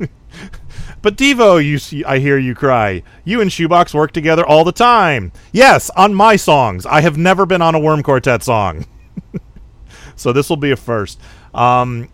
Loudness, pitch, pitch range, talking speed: -12 LUFS, 150 Hz, 125-175 Hz, 180 wpm